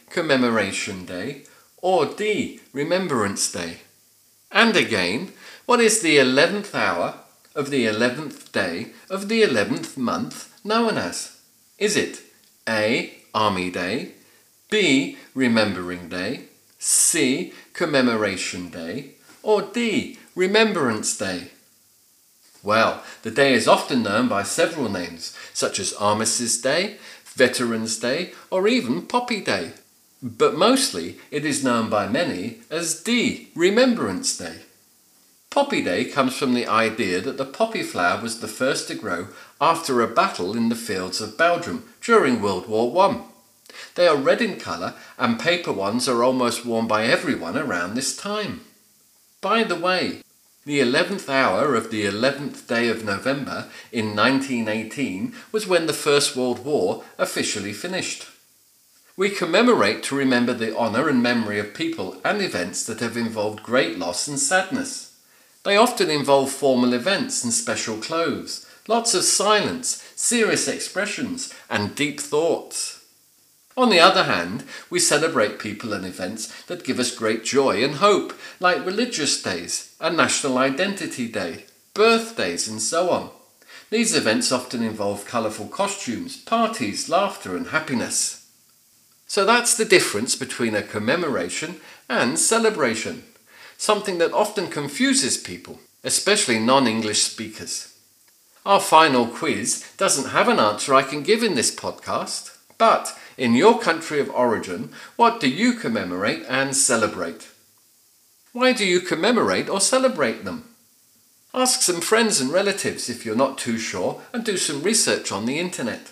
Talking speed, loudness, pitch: 140 wpm, -21 LUFS, 180 Hz